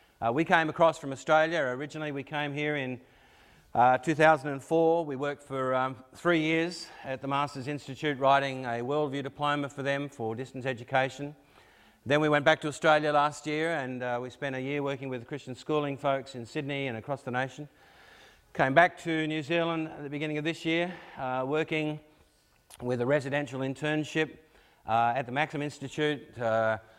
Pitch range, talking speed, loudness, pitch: 130-155 Hz, 180 wpm, -29 LUFS, 145 Hz